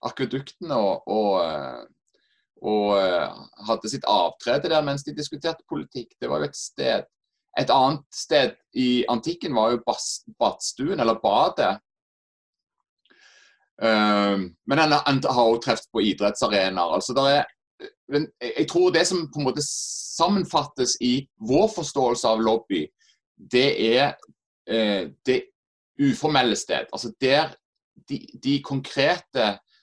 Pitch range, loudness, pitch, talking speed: 110-155 Hz, -23 LUFS, 135 Hz, 120 wpm